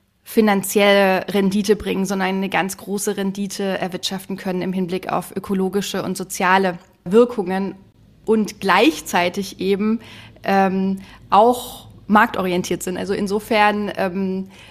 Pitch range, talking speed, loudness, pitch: 185-205 Hz, 110 wpm, -19 LUFS, 195 Hz